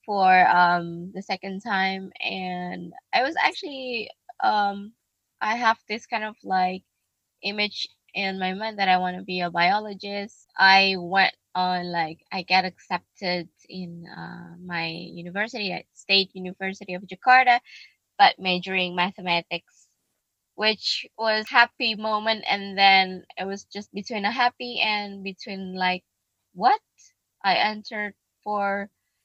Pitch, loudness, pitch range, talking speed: 195 Hz, -23 LUFS, 180-215 Hz, 135 wpm